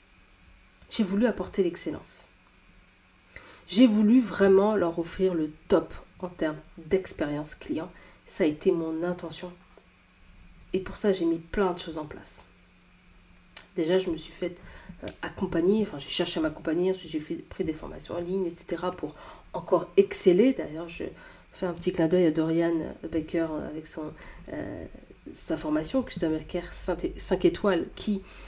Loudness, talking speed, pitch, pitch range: -28 LUFS, 150 wpm, 170 Hz, 155-185 Hz